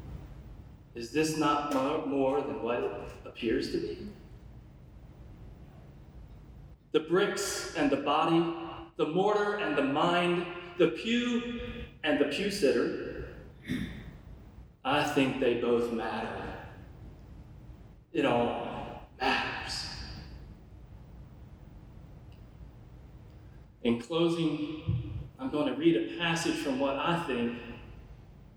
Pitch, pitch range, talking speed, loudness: 140 Hz, 115-170 Hz, 95 wpm, -31 LUFS